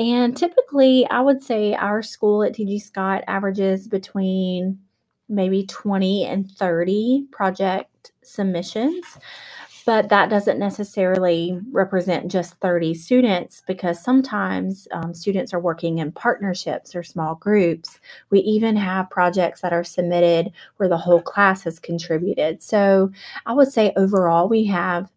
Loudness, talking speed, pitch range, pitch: -20 LUFS, 135 wpm, 175-215 Hz, 195 Hz